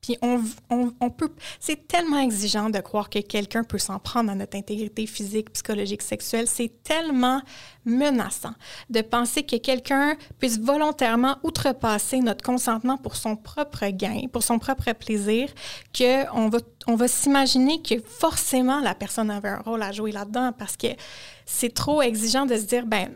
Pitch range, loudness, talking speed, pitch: 215-265 Hz, -24 LUFS, 170 wpm, 240 Hz